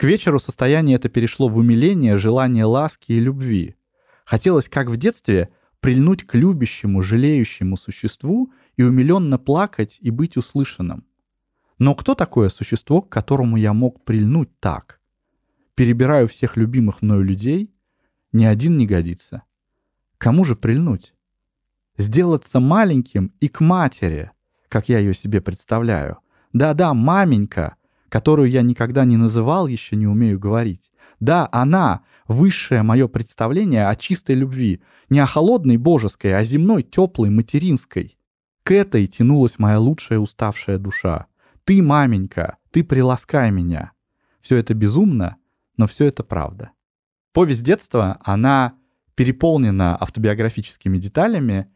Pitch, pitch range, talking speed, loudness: 120 Hz, 105-140 Hz, 130 wpm, -18 LUFS